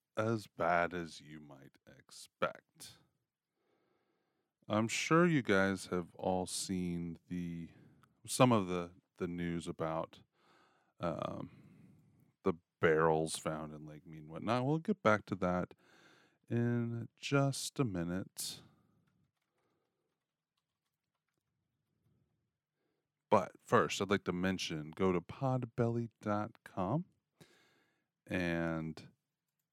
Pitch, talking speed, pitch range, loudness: 95 Hz, 95 wpm, 85-120 Hz, -36 LUFS